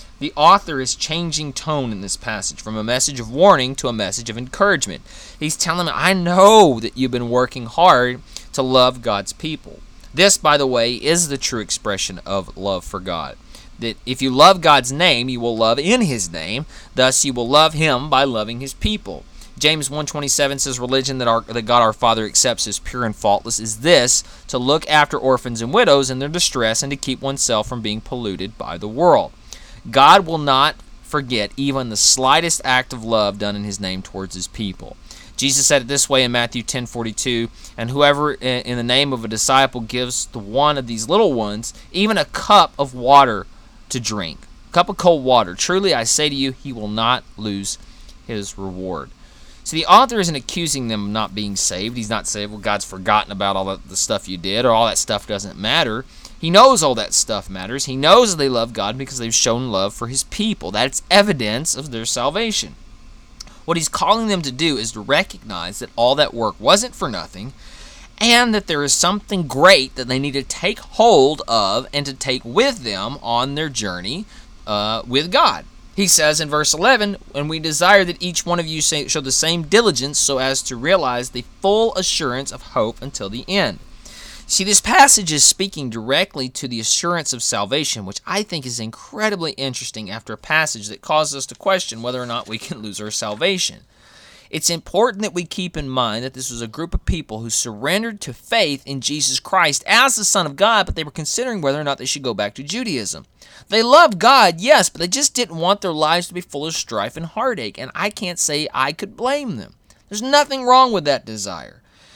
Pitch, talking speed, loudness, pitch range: 135 Hz, 210 wpm, -17 LUFS, 115-165 Hz